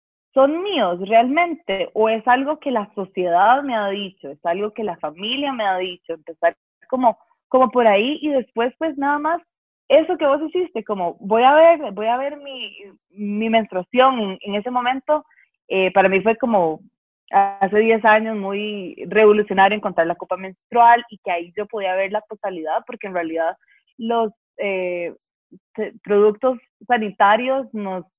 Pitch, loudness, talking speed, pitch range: 215 Hz, -19 LUFS, 170 wpm, 195-255 Hz